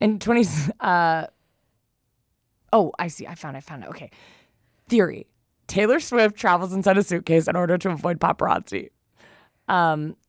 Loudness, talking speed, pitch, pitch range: -21 LUFS, 150 wpm, 170 Hz, 150-190 Hz